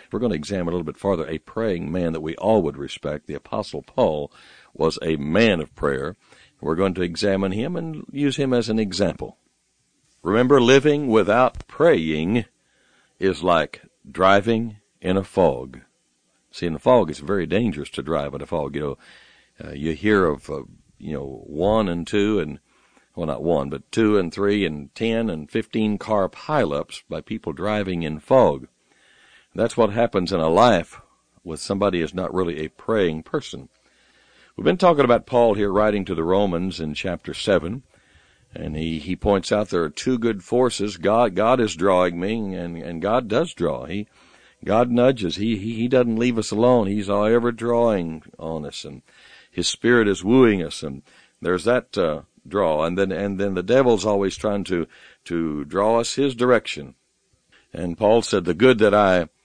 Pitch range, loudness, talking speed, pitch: 85-115 Hz, -21 LUFS, 185 wpm, 100 Hz